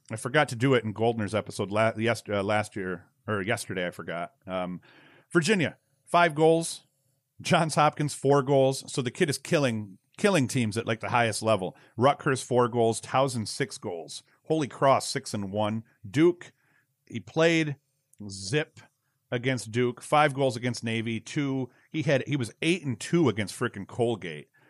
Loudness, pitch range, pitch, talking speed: -27 LUFS, 110-140 Hz, 125 Hz, 165 wpm